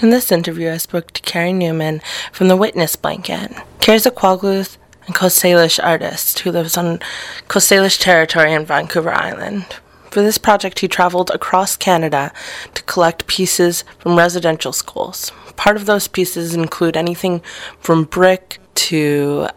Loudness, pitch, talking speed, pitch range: -15 LUFS, 175 Hz, 155 wpm, 165-190 Hz